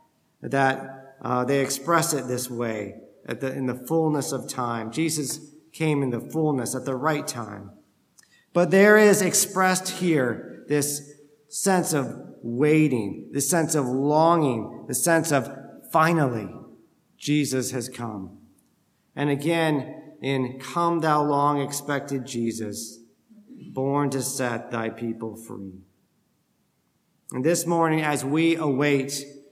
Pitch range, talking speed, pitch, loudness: 125-155 Hz, 125 wpm, 140 Hz, -24 LUFS